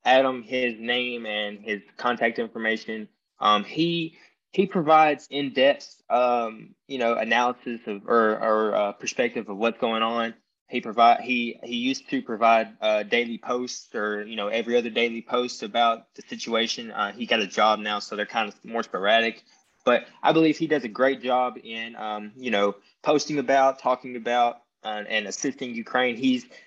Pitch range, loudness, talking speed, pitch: 110-130 Hz, -24 LUFS, 175 wpm, 120 Hz